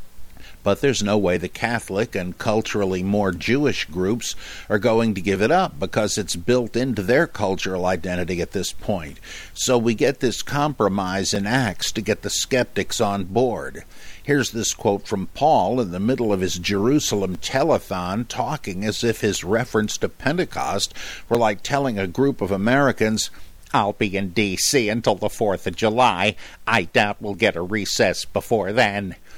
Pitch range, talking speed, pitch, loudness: 95-120 Hz, 170 wpm, 105 Hz, -21 LUFS